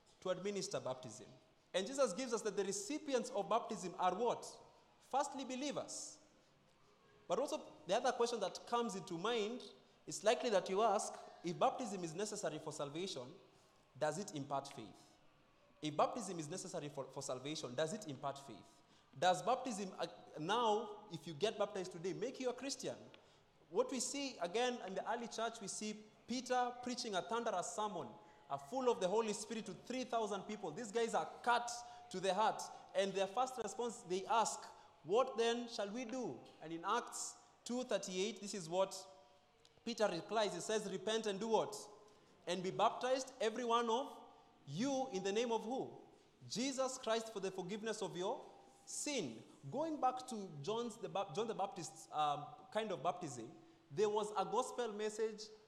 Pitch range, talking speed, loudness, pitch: 180-240 Hz, 170 wpm, -41 LUFS, 210 Hz